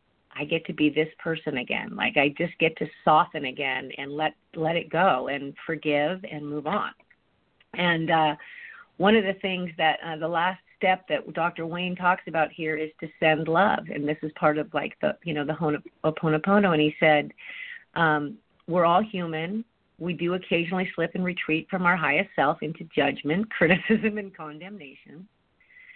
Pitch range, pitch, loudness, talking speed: 155-185 Hz, 165 Hz, -25 LUFS, 185 wpm